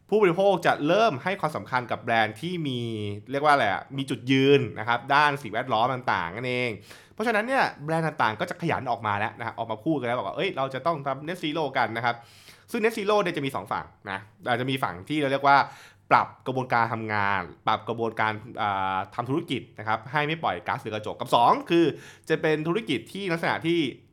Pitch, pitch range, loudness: 130 Hz, 110-160 Hz, -26 LUFS